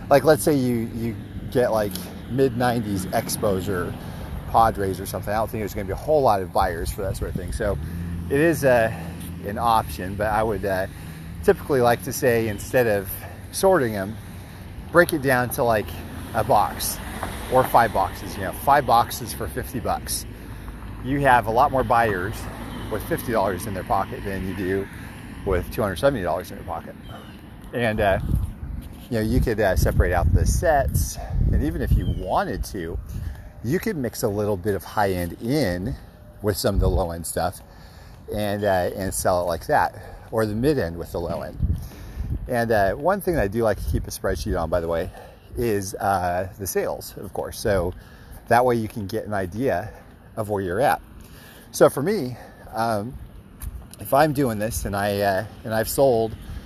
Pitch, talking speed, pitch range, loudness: 100 Hz, 195 wpm, 90-115 Hz, -23 LUFS